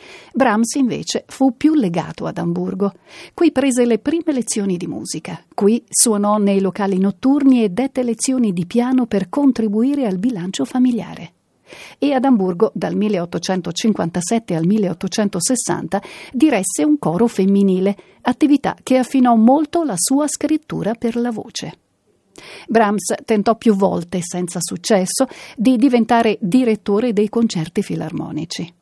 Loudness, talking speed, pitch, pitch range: -17 LUFS, 130 wpm, 220 Hz, 195-255 Hz